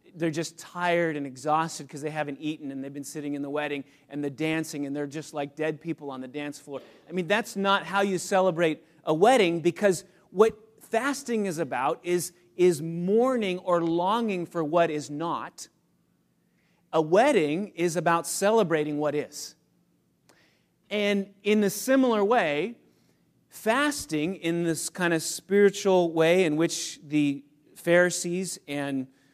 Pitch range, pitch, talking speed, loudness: 150-190 Hz, 170 Hz, 155 wpm, -26 LUFS